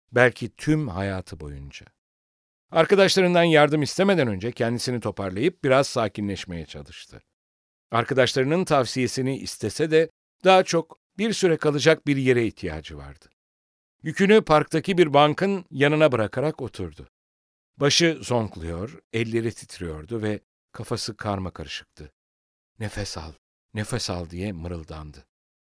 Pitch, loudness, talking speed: 115 Hz, -23 LUFS, 110 wpm